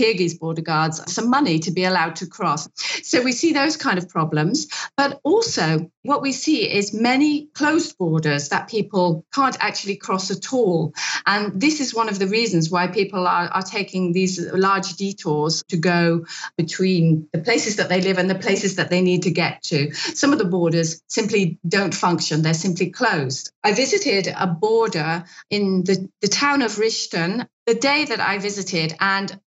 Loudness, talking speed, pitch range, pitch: -20 LUFS, 185 wpm, 170-225 Hz, 190 Hz